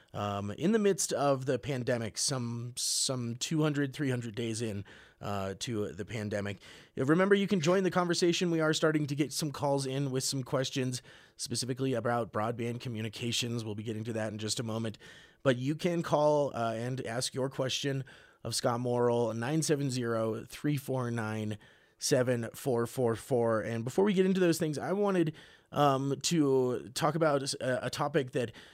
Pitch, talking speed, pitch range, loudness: 130 Hz, 165 wpm, 115-150 Hz, -31 LUFS